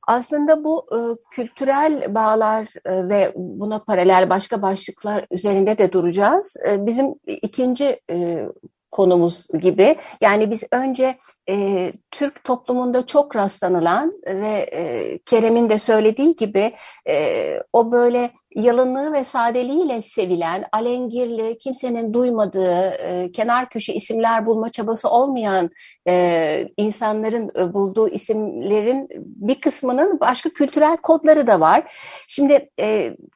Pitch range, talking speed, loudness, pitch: 205-270 Hz, 115 wpm, -19 LUFS, 230 Hz